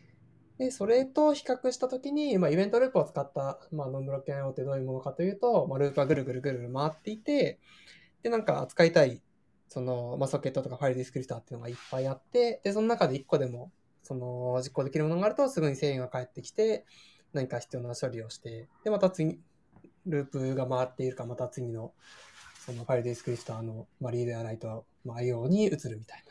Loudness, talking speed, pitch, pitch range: -31 LUFS, 460 characters per minute, 135 Hz, 125-180 Hz